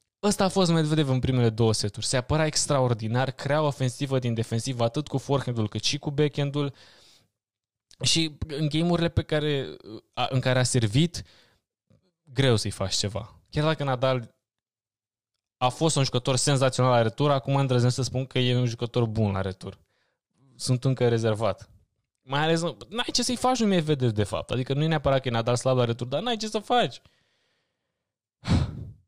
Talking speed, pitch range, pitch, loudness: 180 wpm, 115-150 Hz, 130 Hz, -25 LUFS